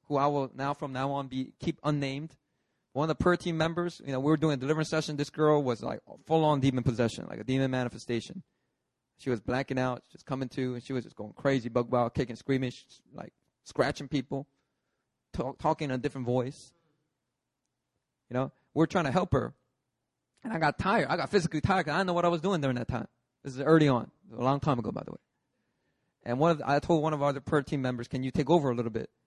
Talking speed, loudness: 250 wpm, -30 LUFS